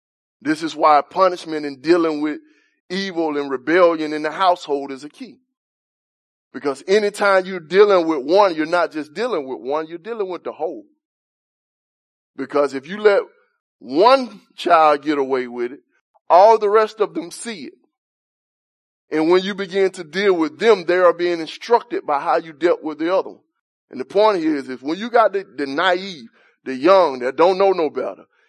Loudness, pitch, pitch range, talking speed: -18 LUFS, 185 Hz, 155-225 Hz, 185 wpm